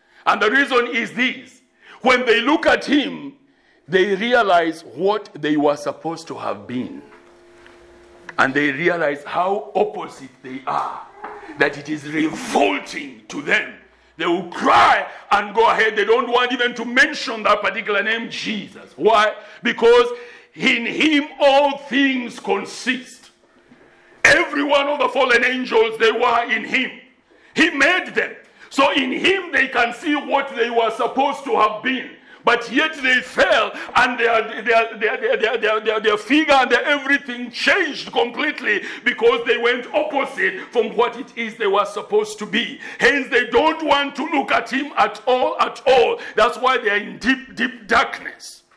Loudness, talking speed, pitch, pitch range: -18 LUFS, 165 wpm, 250 Hz, 225-280 Hz